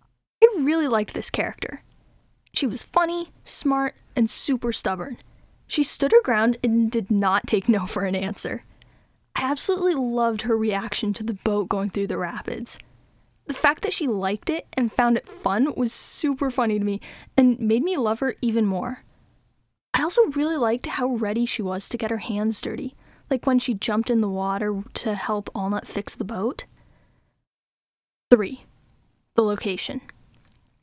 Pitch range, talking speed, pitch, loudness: 210-270 Hz, 170 wpm, 230 Hz, -24 LUFS